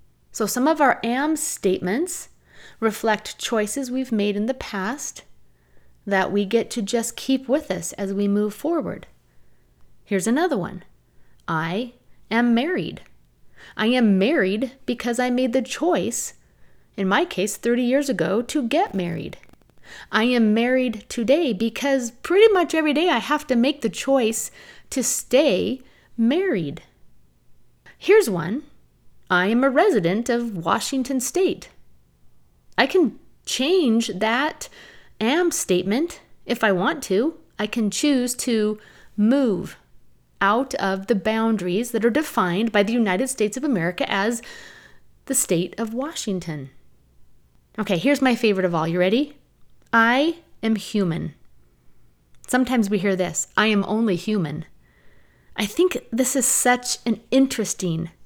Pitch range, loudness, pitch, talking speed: 190-260 Hz, -22 LUFS, 225 Hz, 140 wpm